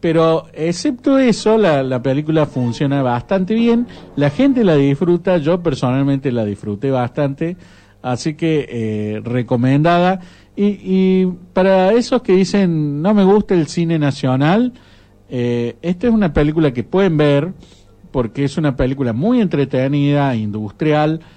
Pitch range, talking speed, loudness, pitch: 130-185 Hz, 140 wpm, -16 LUFS, 155 Hz